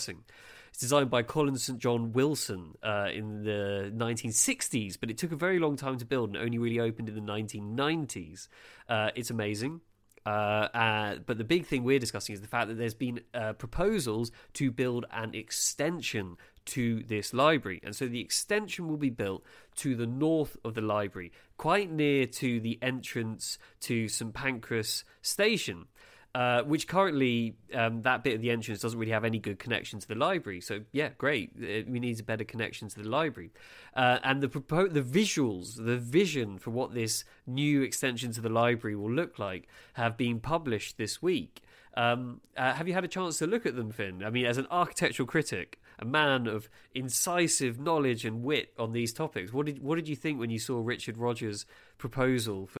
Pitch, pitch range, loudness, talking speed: 120 Hz, 110-140 Hz, -31 LUFS, 195 wpm